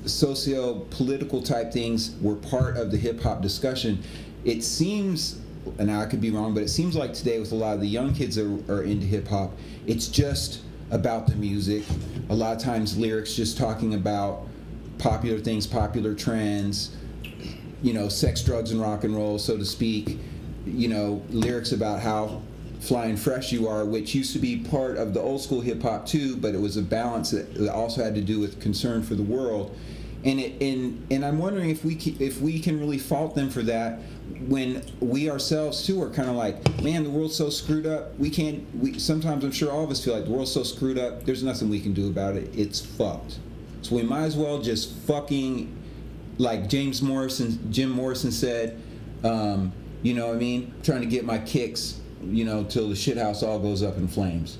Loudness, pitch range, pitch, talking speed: -27 LUFS, 105-135 Hz, 115 Hz, 210 wpm